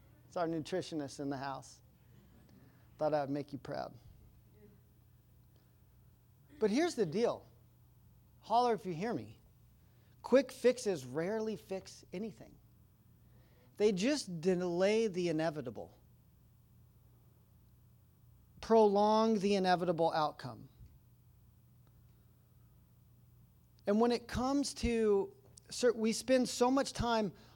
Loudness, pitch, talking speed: -34 LUFS, 165 Hz, 100 wpm